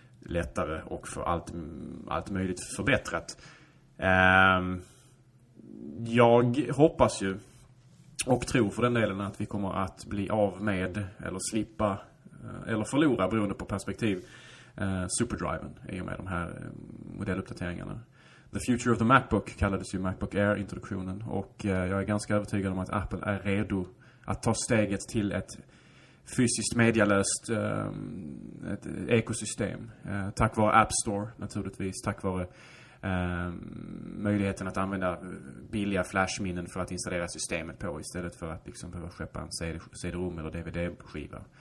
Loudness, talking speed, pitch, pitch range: -30 LUFS, 135 wpm, 100 Hz, 95-115 Hz